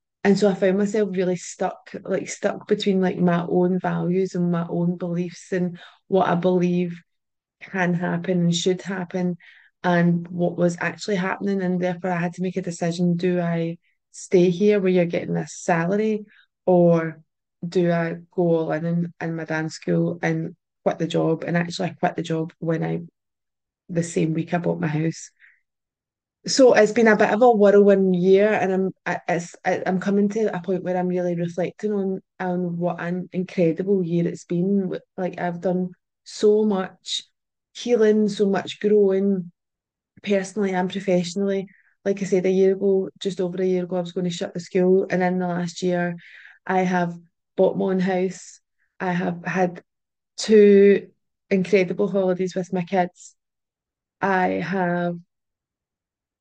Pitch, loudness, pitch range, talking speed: 180 Hz, -22 LUFS, 175-190 Hz, 170 wpm